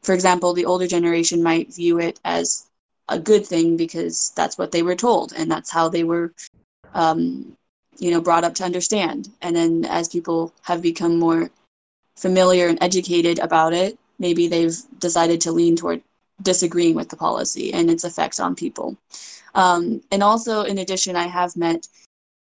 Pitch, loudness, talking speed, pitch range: 170 Hz, -20 LUFS, 175 wpm, 165-180 Hz